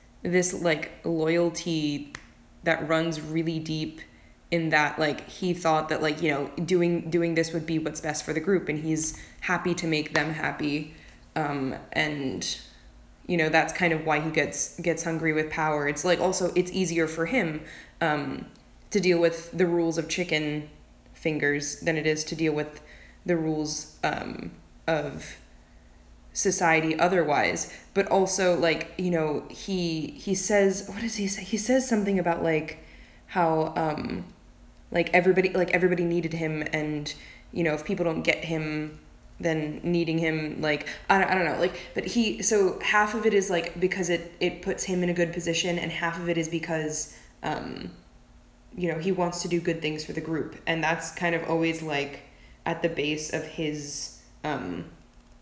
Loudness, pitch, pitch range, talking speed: -27 LUFS, 165 Hz, 155-175 Hz, 180 wpm